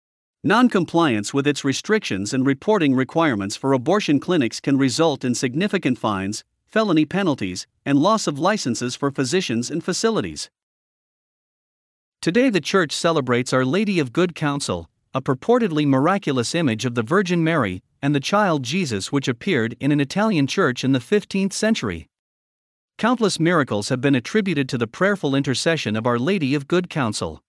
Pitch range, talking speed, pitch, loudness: 130-180 Hz, 155 wpm, 145 Hz, -21 LUFS